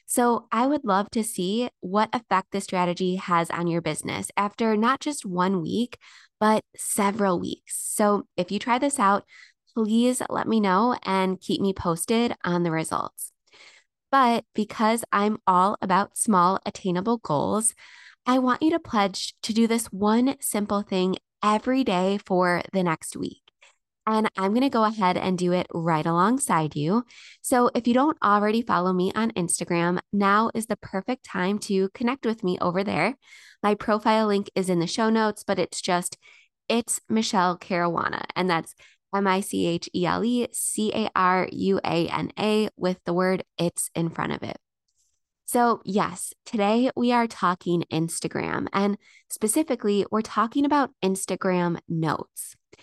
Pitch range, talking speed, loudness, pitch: 180-225 Hz, 170 wpm, -24 LUFS, 200 Hz